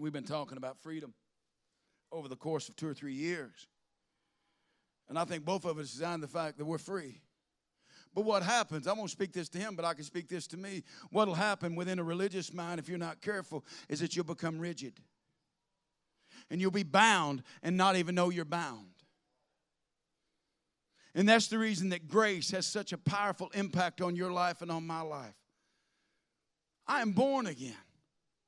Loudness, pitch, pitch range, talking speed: -34 LUFS, 175 Hz, 155-190 Hz, 185 wpm